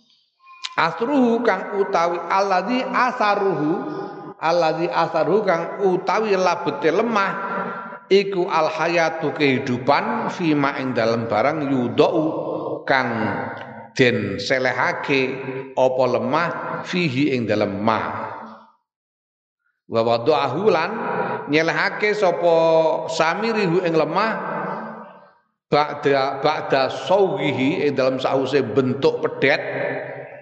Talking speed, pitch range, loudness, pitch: 85 wpm, 130-195 Hz, -20 LUFS, 160 Hz